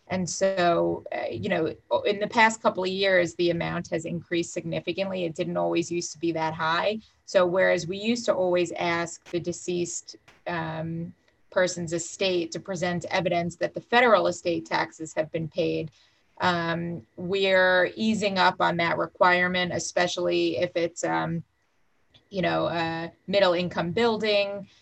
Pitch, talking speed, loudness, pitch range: 175 Hz, 155 wpm, -26 LUFS, 165-185 Hz